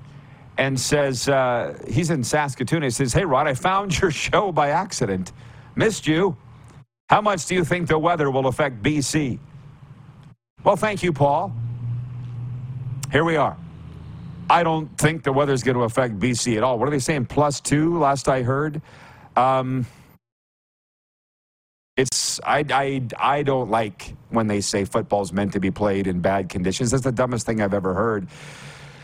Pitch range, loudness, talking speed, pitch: 120-150 Hz, -22 LUFS, 165 wpm, 135 Hz